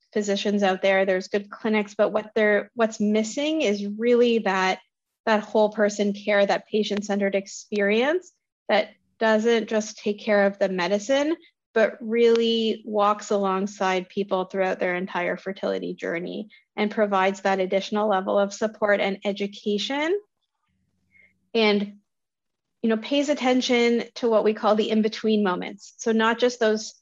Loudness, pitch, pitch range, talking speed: -23 LUFS, 210 Hz, 200-225 Hz, 145 wpm